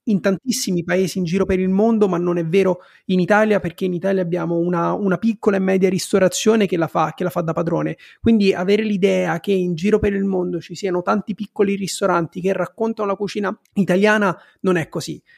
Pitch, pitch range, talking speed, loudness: 190 Hz, 180-205 Hz, 210 wpm, -19 LUFS